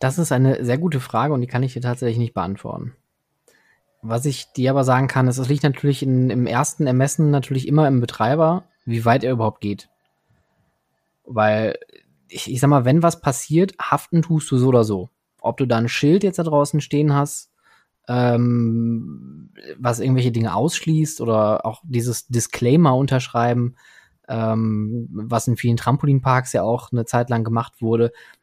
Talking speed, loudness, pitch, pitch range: 175 wpm, -20 LUFS, 125 Hz, 115-145 Hz